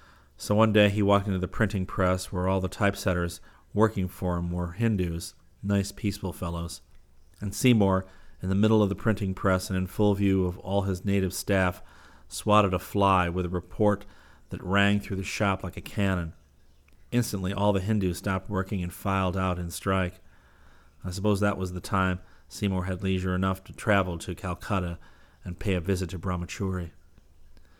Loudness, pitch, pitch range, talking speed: -27 LUFS, 95 Hz, 85-100 Hz, 180 wpm